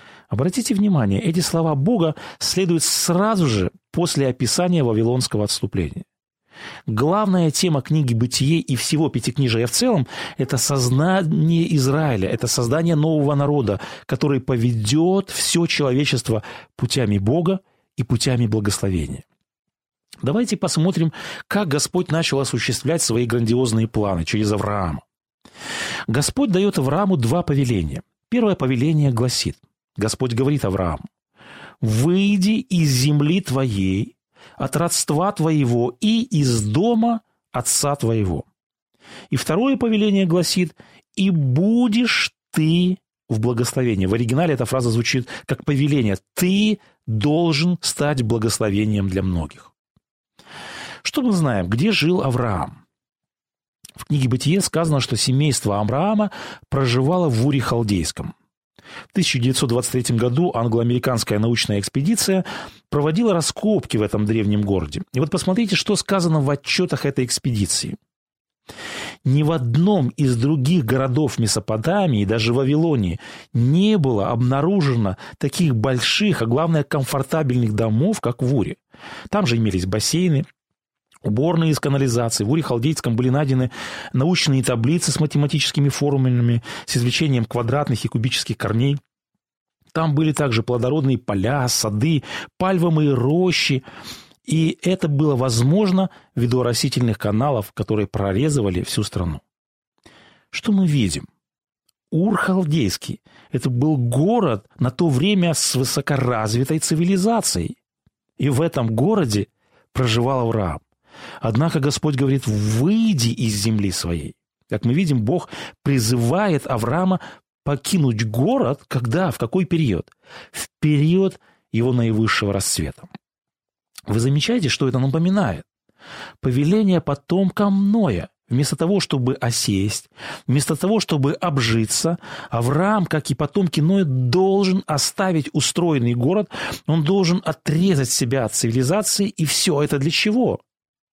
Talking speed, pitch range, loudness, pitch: 115 wpm, 120-170 Hz, -20 LUFS, 140 Hz